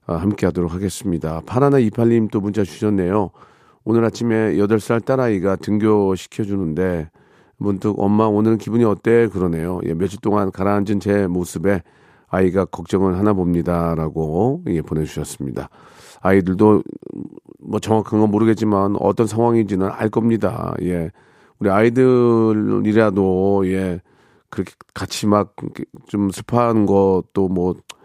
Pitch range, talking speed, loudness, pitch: 95-110 Hz, 295 characters per minute, -18 LUFS, 100 Hz